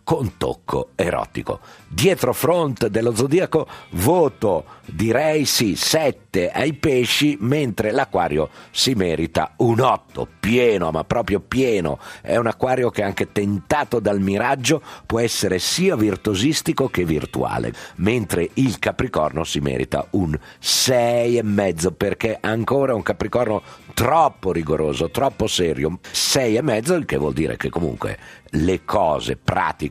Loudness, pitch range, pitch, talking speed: -20 LUFS, 100-130 Hz, 110 Hz, 135 wpm